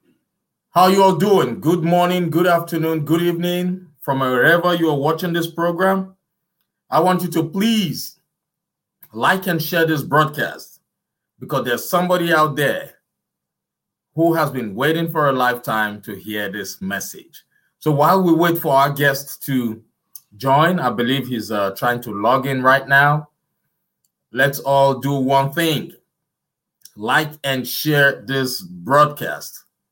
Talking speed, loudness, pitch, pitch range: 145 wpm, -18 LUFS, 155 Hz, 135-175 Hz